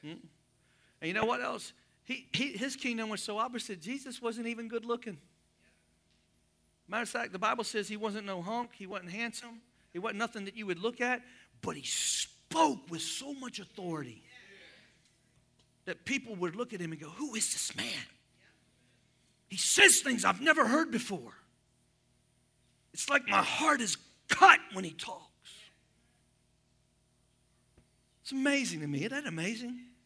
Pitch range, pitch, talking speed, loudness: 175-245 Hz, 220 Hz, 160 wpm, -31 LUFS